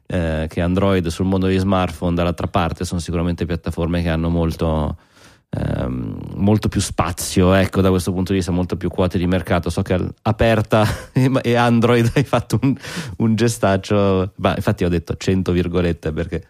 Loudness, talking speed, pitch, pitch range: -19 LUFS, 170 wpm, 95 Hz, 85-105 Hz